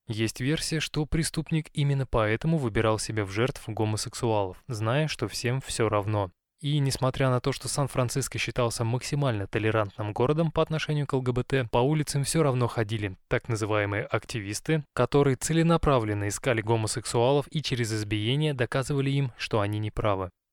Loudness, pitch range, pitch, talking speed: -27 LUFS, 110-140 Hz, 125 Hz, 145 wpm